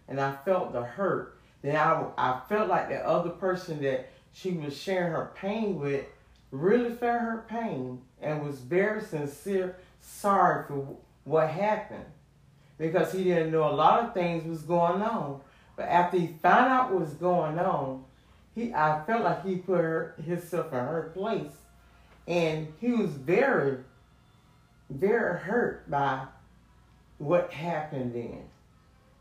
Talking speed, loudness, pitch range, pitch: 150 wpm, -28 LUFS, 140-185 Hz, 165 Hz